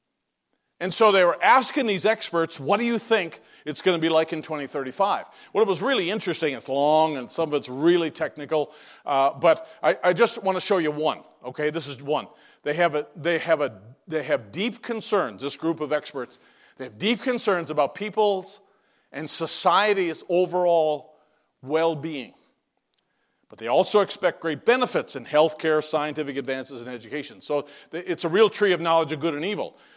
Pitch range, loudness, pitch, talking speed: 150-195 Hz, -24 LUFS, 165 Hz, 185 wpm